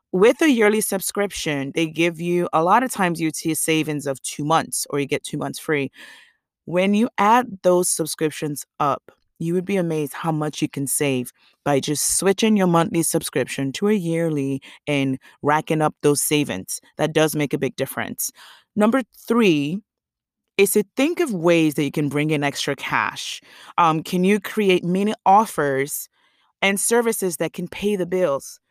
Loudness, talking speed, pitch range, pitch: -21 LUFS, 180 wpm, 150-195 Hz, 165 Hz